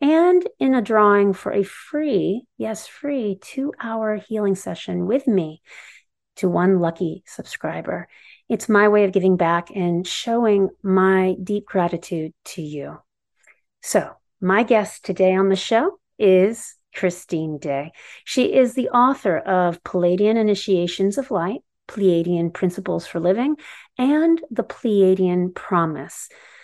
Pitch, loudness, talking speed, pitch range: 195 Hz, -20 LUFS, 135 wpm, 180-235 Hz